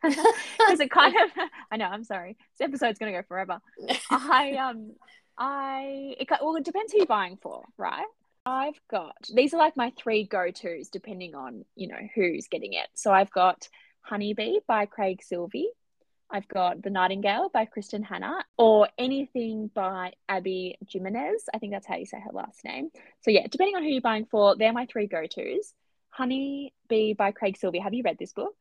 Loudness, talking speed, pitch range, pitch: -27 LUFS, 185 wpm, 200-275 Hz, 225 Hz